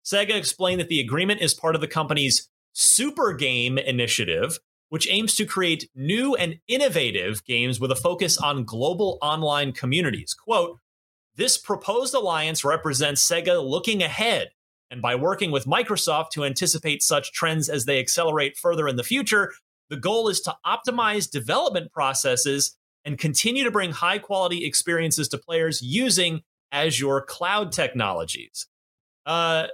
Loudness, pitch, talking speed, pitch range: -22 LUFS, 160 Hz, 145 wpm, 140-195 Hz